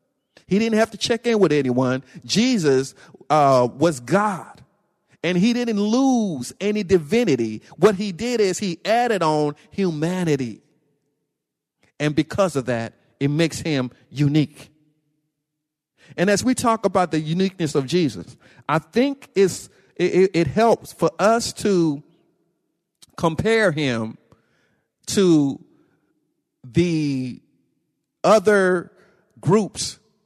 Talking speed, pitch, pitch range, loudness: 115 wpm, 165 Hz, 145-205 Hz, -20 LUFS